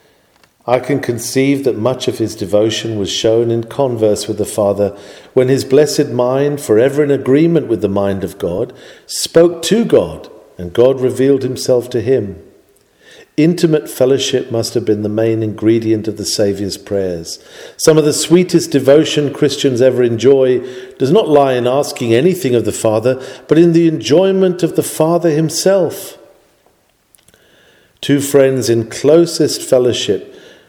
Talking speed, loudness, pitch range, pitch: 155 wpm, -13 LUFS, 115-155 Hz, 130 Hz